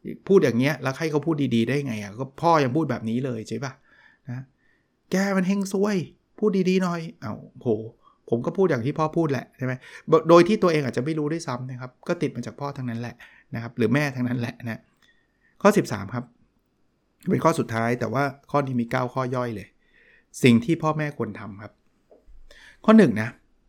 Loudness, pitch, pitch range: -24 LUFS, 135 Hz, 120-165 Hz